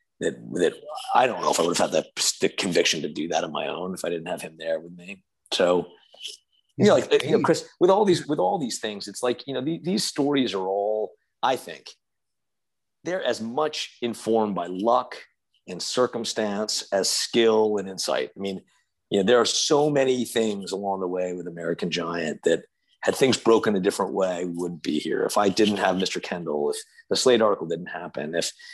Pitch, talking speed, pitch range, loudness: 110 Hz, 210 wpm, 95-150 Hz, -24 LUFS